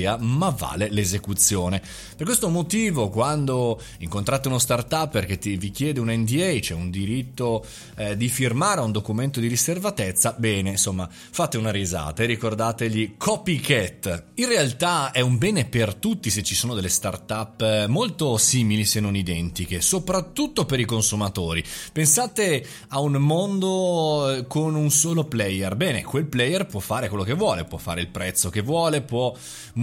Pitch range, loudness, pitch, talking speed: 100-150 Hz, -23 LUFS, 115 Hz, 155 wpm